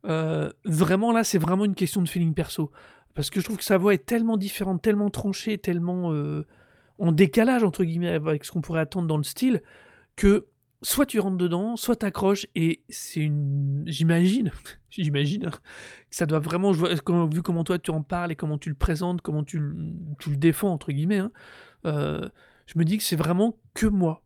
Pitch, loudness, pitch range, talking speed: 175 Hz, -25 LUFS, 160-200 Hz, 205 wpm